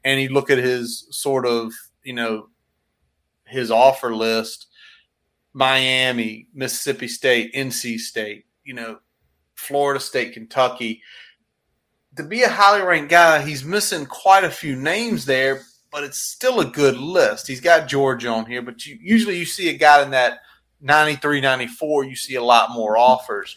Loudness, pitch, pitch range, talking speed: -18 LUFS, 130 Hz, 120-150 Hz, 165 wpm